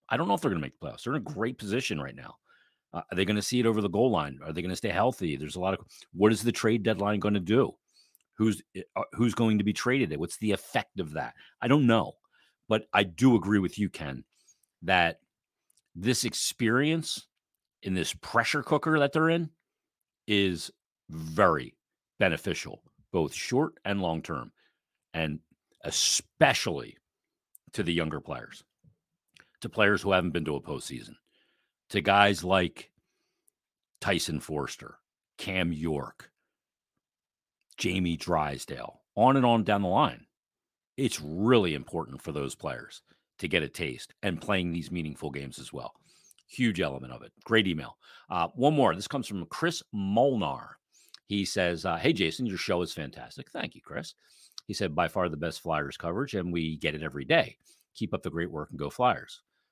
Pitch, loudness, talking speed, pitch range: 100 Hz, -29 LUFS, 180 wpm, 85-115 Hz